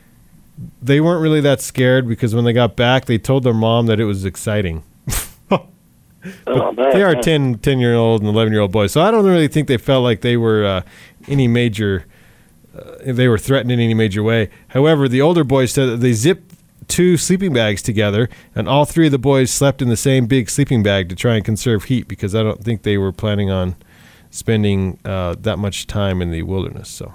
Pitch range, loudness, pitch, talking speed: 105-135 Hz, -16 LUFS, 120 Hz, 215 wpm